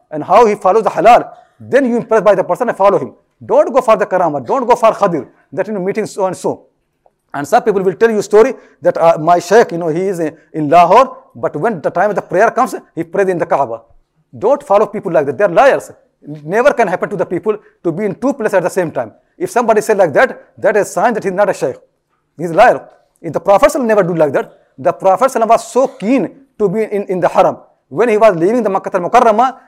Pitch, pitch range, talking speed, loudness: 205 Hz, 175-230 Hz, 265 wpm, -13 LUFS